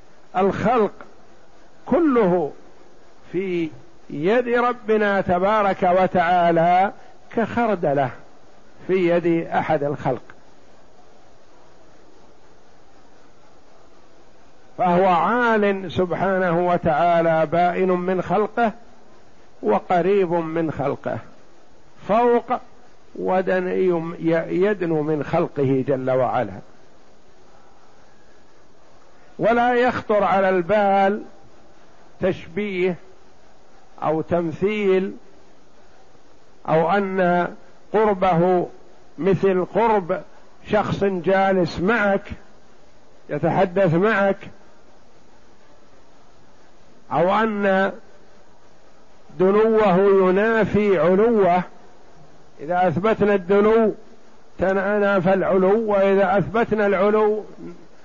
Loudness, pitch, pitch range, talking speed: -20 LUFS, 190 Hz, 175-205 Hz, 60 wpm